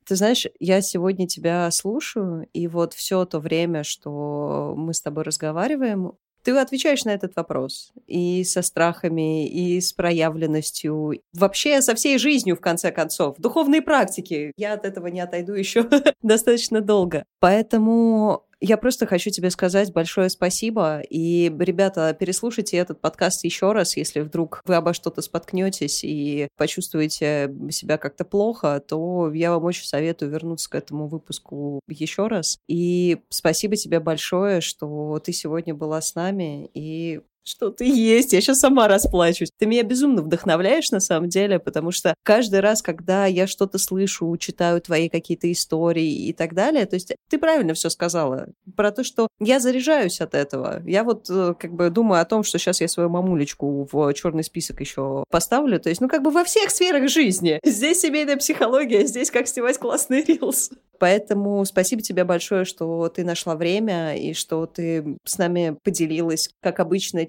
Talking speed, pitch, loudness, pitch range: 165 wpm, 180 Hz, -21 LUFS, 165-210 Hz